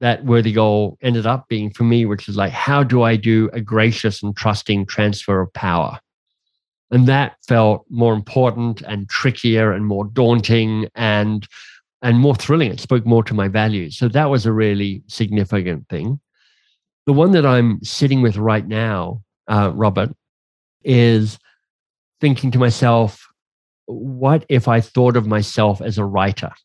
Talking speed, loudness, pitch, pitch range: 160 wpm, -17 LUFS, 110 Hz, 105-120 Hz